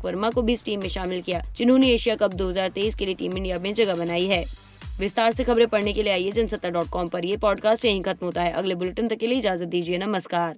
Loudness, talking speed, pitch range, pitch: -24 LUFS, 250 wpm, 180-220 Hz, 195 Hz